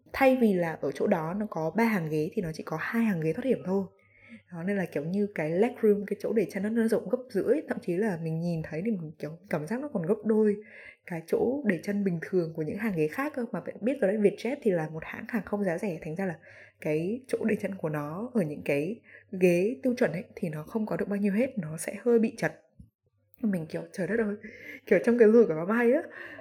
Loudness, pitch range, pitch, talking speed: -29 LUFS, 165-225 Hz, 200 Hz, 275 wpm